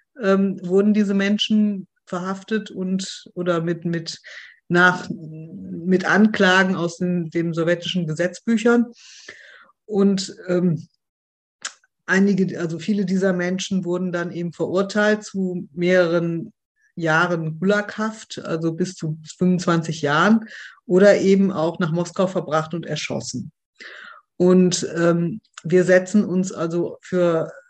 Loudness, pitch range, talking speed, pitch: -20 LUFS, 170-200 Hz, 115 wpm, 180 Hz